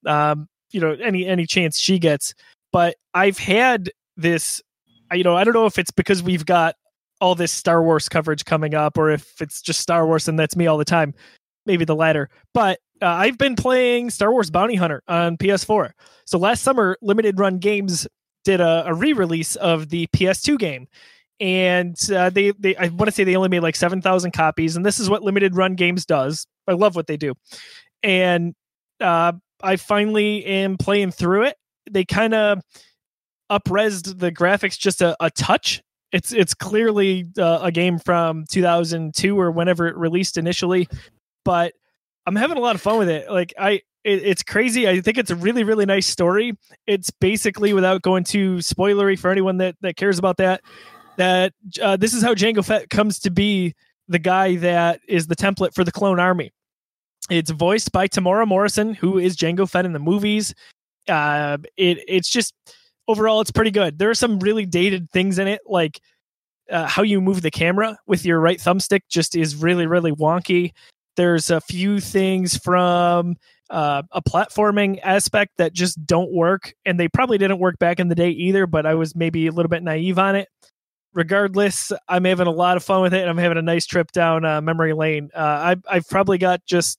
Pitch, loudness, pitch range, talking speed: 185 Hz, -19 LUFS, 170-200 Hz, 195 wpm